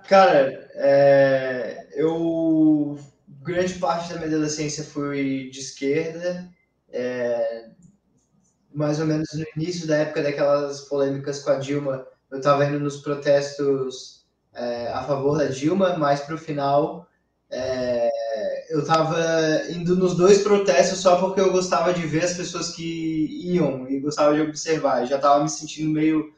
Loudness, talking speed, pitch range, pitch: -22 LUFS, 145 wpm, 140-170 Hz, 150 Hz